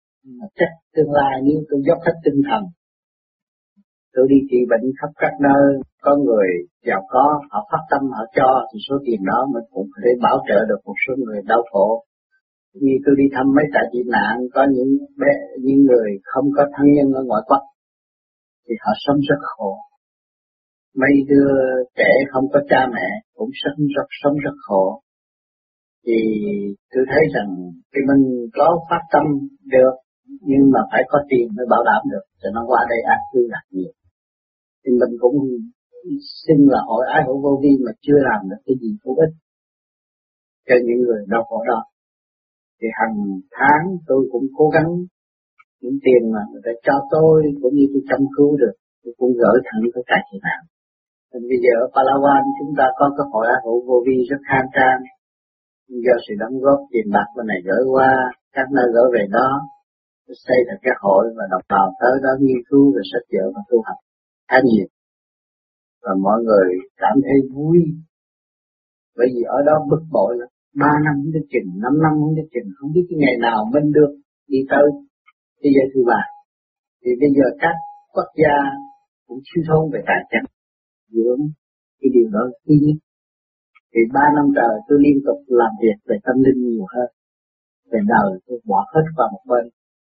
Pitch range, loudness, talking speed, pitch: 120-150 Hz, -17 LUFS, 190 wpm, 135 Hz